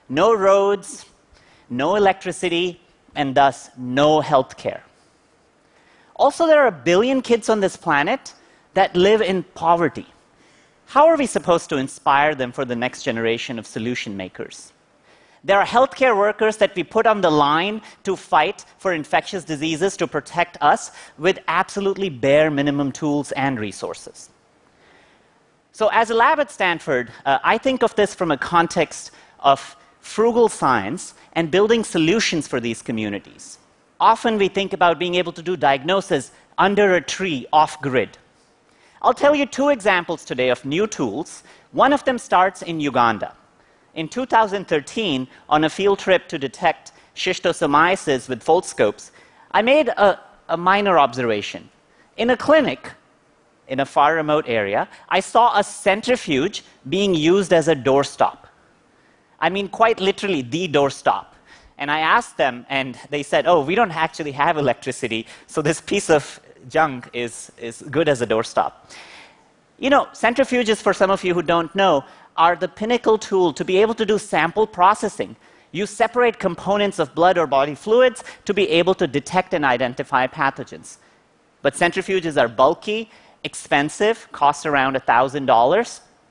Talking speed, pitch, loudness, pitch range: 155 wpm, 180 Hz, -19 LUFS, 145-210 Hz